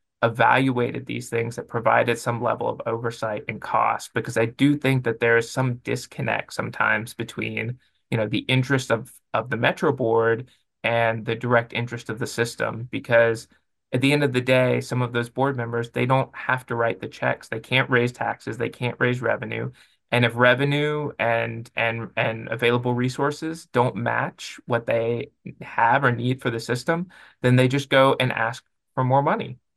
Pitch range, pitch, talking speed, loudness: 115-130 Hz, 120 Hz, 185 wpm, -23 LUFS